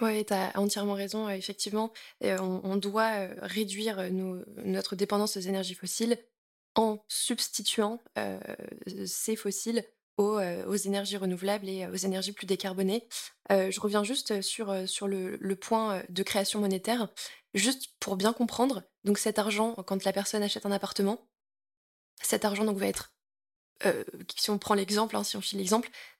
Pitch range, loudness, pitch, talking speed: 195-220 Hz, -31 LUFS, 205 Hz, 155 wpm